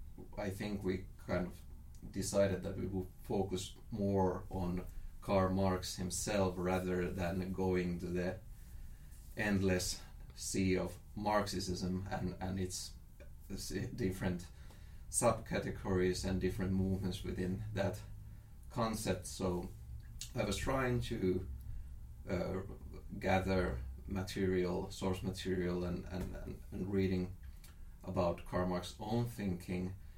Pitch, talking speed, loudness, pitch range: 95 Hz, 105 wpm, -38 LUFS, 90-95 Hz